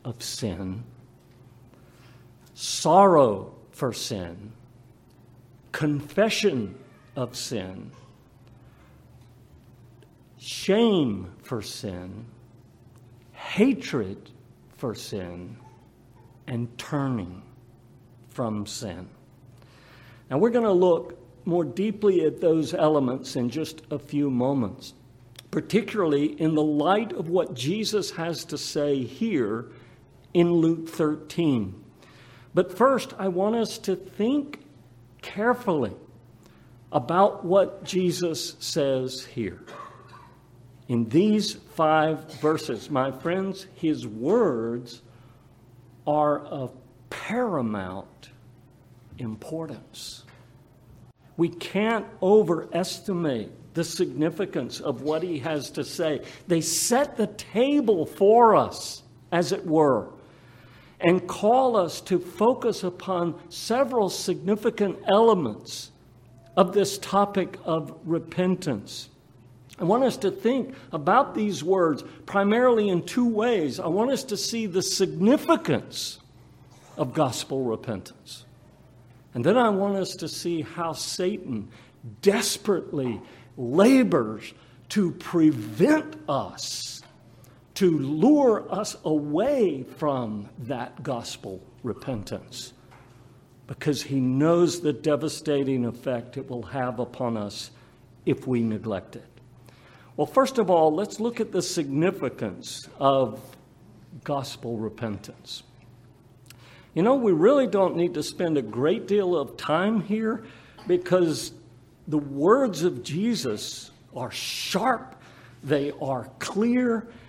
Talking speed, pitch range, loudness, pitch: 105 wpm, 125-185 Hz, -25 LUFS, 150 Hz